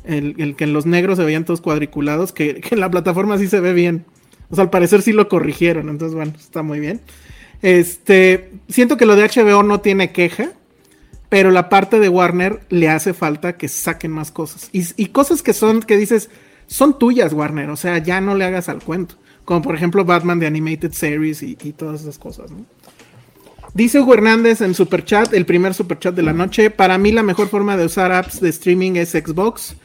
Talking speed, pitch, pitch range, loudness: 215 wpm, 180 Hz, 160-205 Hz, -15 LUFS